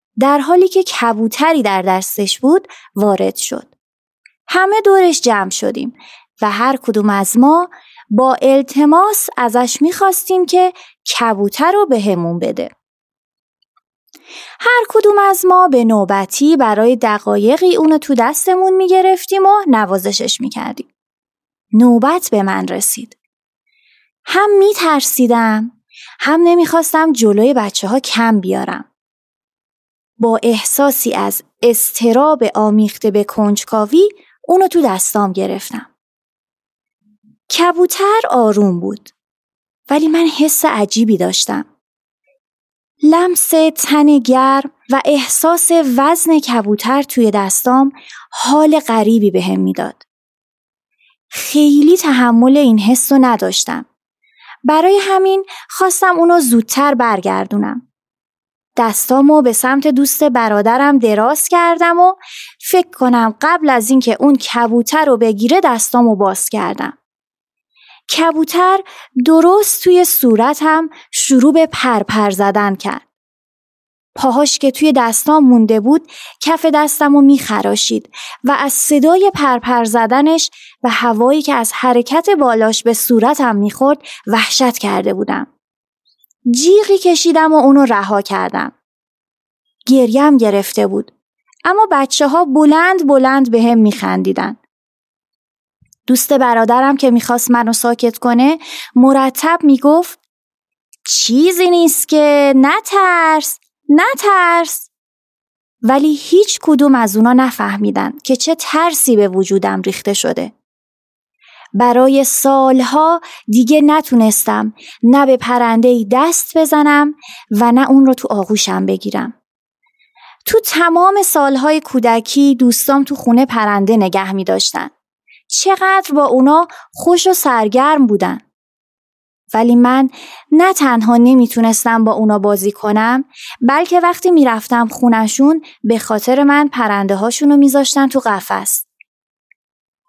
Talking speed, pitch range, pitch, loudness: 110 wpm, 230-320 Hz, 265 Hz, -11 LUFS